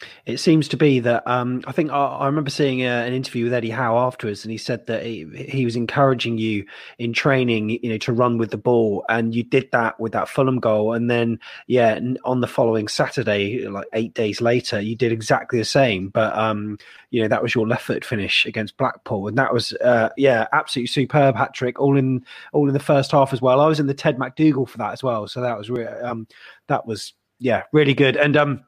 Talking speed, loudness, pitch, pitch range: 235 wpm, -20 LUFS, 125 Hz, 115-135 Hz